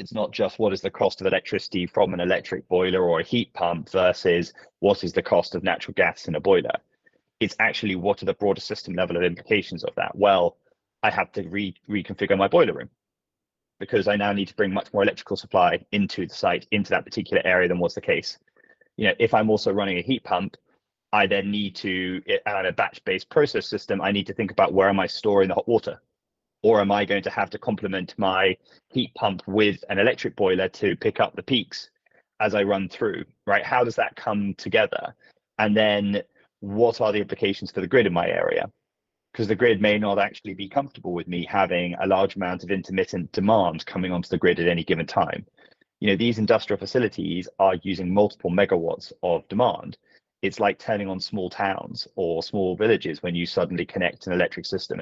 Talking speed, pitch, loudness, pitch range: 210 wpm, 100 Hz, -24 LUFS, 95-105 Hz